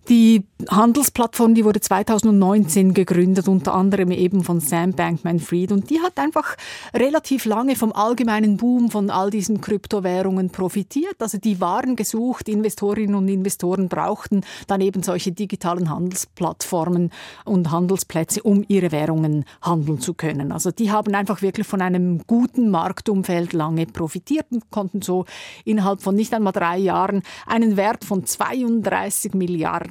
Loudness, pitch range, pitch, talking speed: -20 LUFS, 180-215 Hz, 195 Hz, 145 wpm